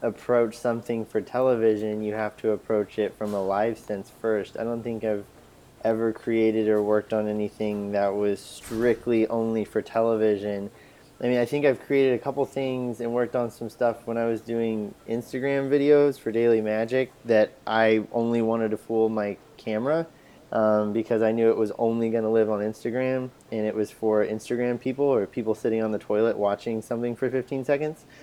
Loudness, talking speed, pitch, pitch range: -25 LUFS, 190 wpm, 115 Hz, 110-120 Hz